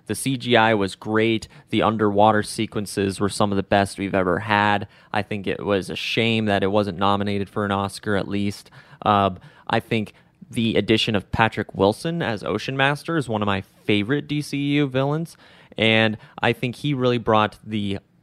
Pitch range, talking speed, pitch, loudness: 100-120 Hz, 180 wpm, 110 Hz, -22 LUFS